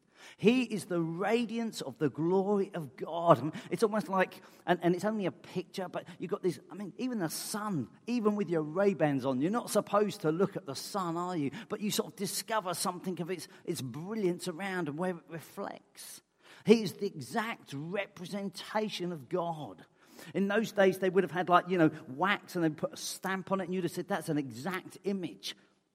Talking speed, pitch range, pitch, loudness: 215 wpm, 170-200 Hz, 185 Hz, -33 LUFS